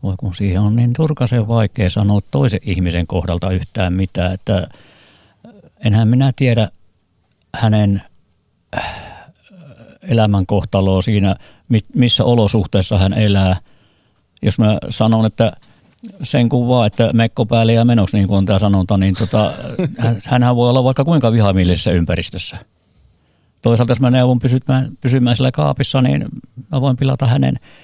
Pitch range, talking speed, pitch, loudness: 95-125 Hz, 135 wpm, 110 Hz, -15 LUFS